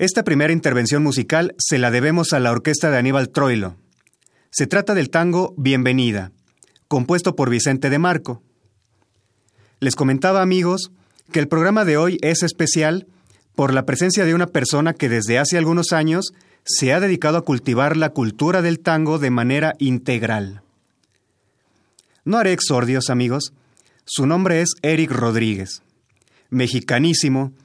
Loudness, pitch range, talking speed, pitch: -18 LUFS, 125-165 Hz, 145 wpm, 140 Hz